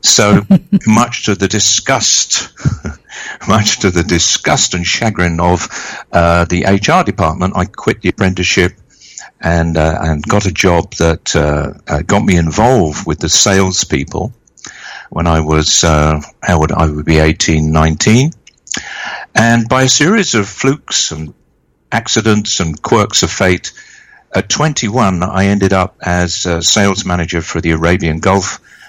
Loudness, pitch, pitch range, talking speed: -12 LUFS, 90 Hz, 80-105 Hz, 145 wpm